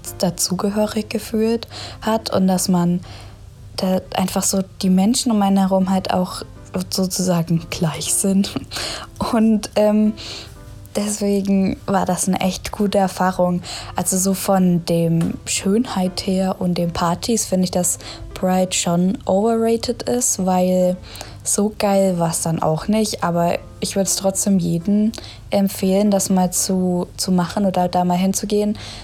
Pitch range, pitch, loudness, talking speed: 175-205 Hz, 190 Hz, -19 LUFS, 140 wpm